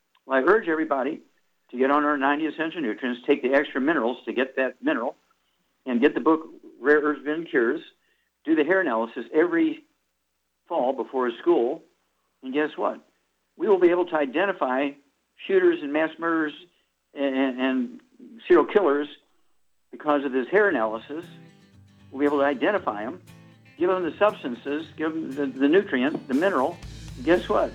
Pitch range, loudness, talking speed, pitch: 135-195 Hz, -24 LUFS, 170 wpm, 150 Hz